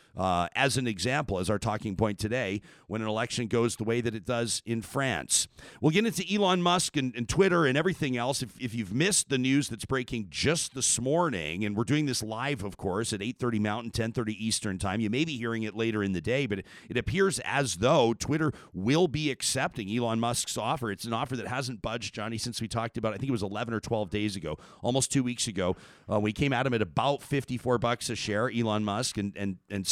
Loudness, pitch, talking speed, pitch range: -29 LUFS, 120 Hz, 240 wpm, 110-135 Hz